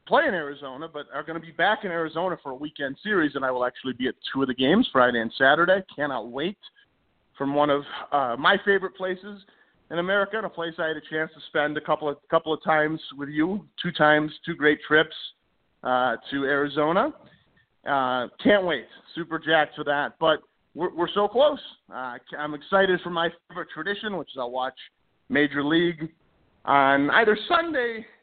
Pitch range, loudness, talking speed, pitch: 145-185 Hz, -24 LUFS, 195 wpm, 160 Hz